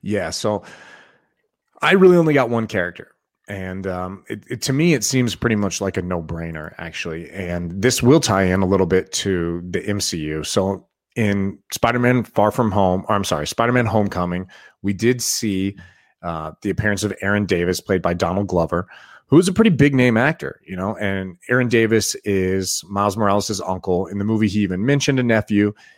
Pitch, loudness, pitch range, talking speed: 100 Hz, -19 LUFS, 95-115 Hz, 195 wpm